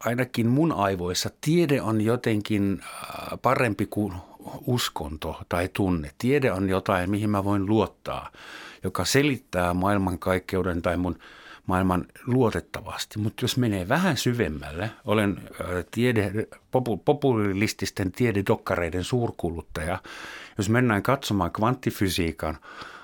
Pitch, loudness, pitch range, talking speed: 105 Hz, -26 LUFS, 90-120 Hz, 105 wpm